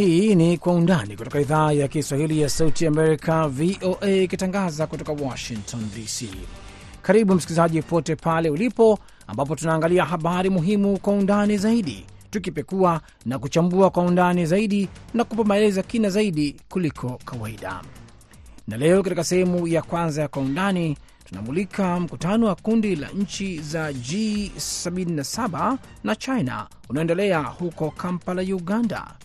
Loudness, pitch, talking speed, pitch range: -22 LUFS, 170 Hz, 130 wpm, 145-190 Hz